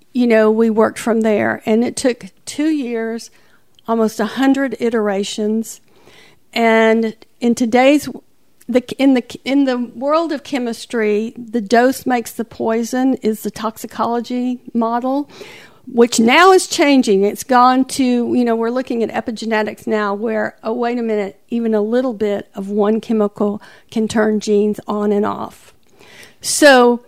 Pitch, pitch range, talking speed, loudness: 230 Hz, 215-250 Hz, 150 wpm, -16 LUFS